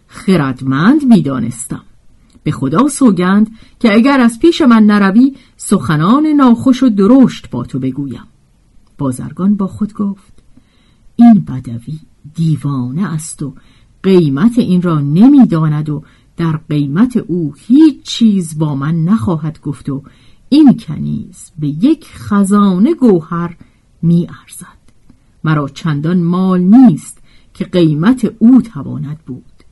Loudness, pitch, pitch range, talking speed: -11 LUFS, 175 Hz, 145-225 Hz, 120 wpm